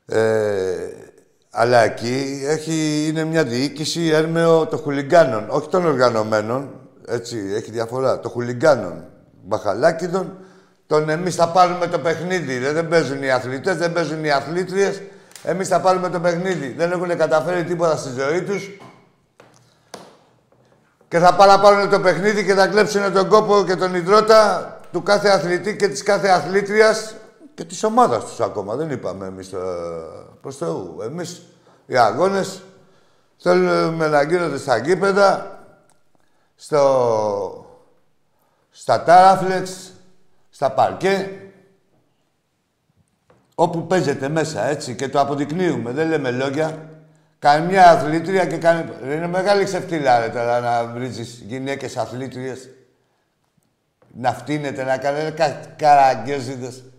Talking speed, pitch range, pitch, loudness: 120 wpm, 140-190 Hz, 165 Hz, -18 LUFS